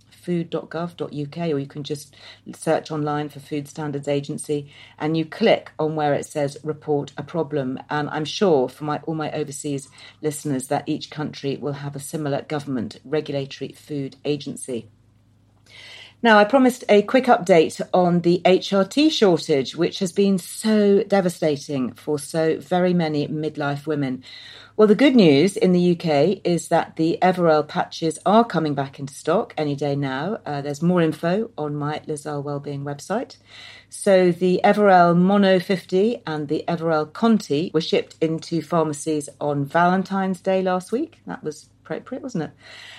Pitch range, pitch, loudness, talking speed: 145-180 Hz, 155 Hz, -21 LUFS, 160 wpm